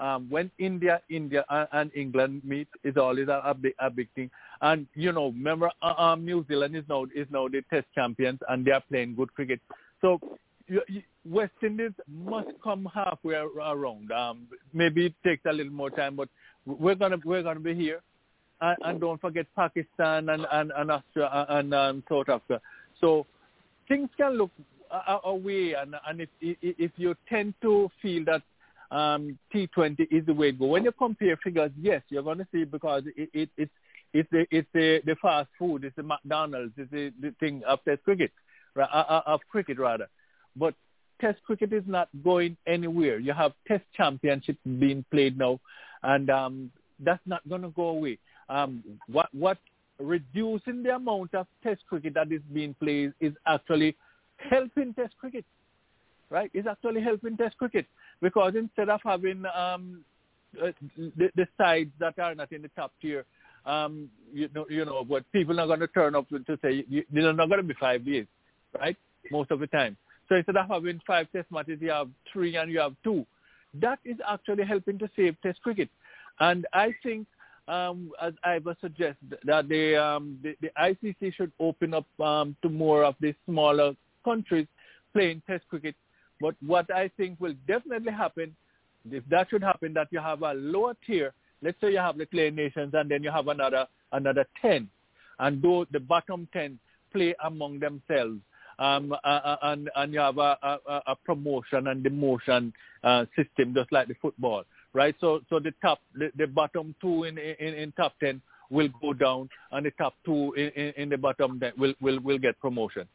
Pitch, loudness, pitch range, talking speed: 155 Hz, -28 LUFS, 145-180 Hz, 185 wpm